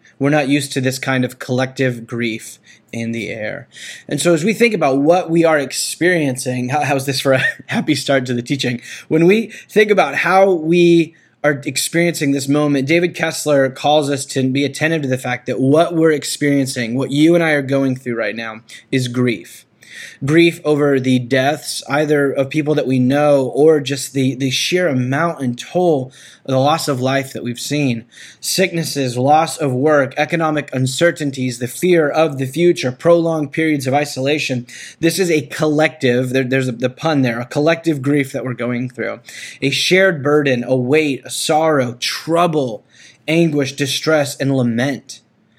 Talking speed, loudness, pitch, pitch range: 180 wpm, -16 LUFS, 140 Hz, 130-160 Hz